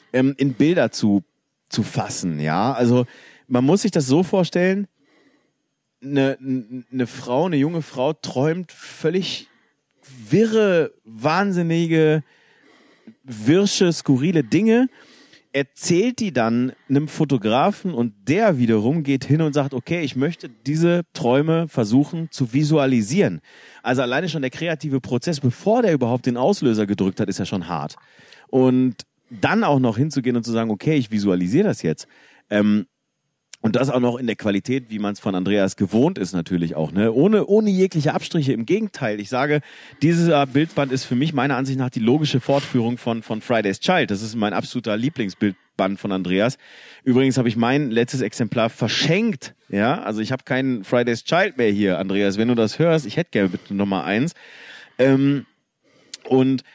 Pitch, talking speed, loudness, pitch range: 130 Hz, 160 wpm, -20 LUFS, 115-155 Hz